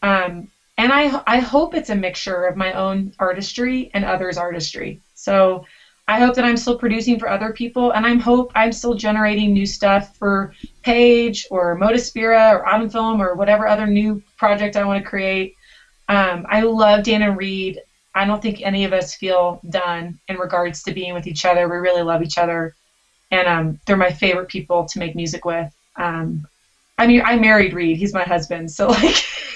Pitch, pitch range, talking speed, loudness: 195 Hz, 180-220 Hz, 195 wpm, -18 LUFS